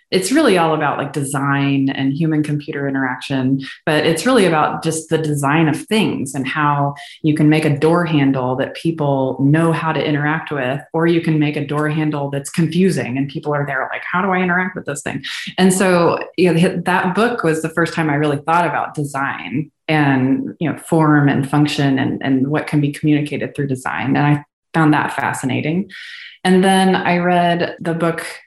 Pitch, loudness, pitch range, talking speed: 150 Hz, -17 LUFS, 140-170 Hz, 200 wpm